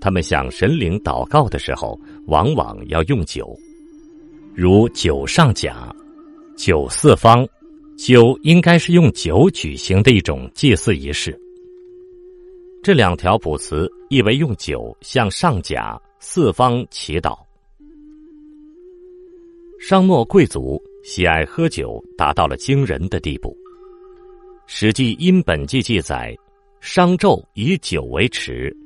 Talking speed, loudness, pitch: 170 characters per minute, -16 LUFS, 200 Hz